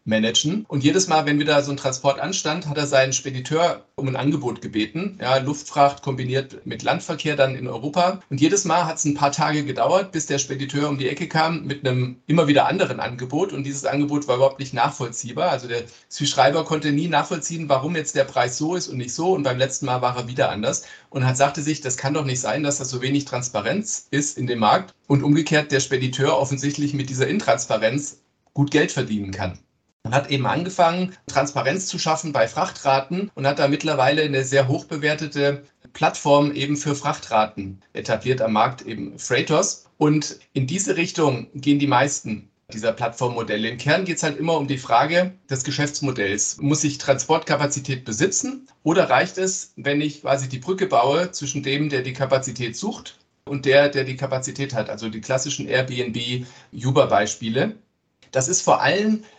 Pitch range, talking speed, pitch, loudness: 130-150 Hz, 190 wpm, 140 Hz, -21 LUFS